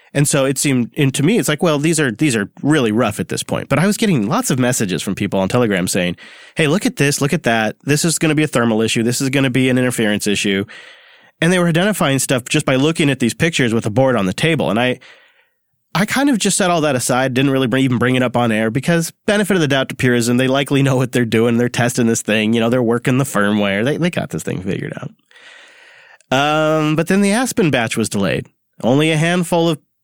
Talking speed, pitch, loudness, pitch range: 265 wpm, 140 Hz, -16 LUFS, 120-165 Hz